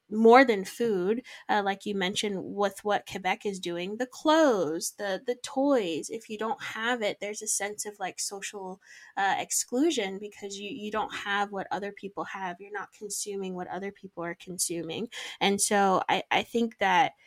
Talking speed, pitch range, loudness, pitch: 185 wpm, 190-225 Hz, -28 LUFS, 200 Hz